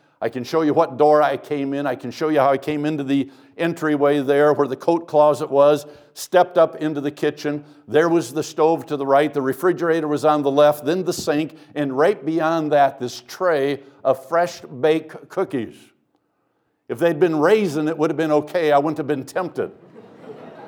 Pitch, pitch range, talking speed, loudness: 150 Hz, 145-160 Hz, 205 wpm, -20 LUFS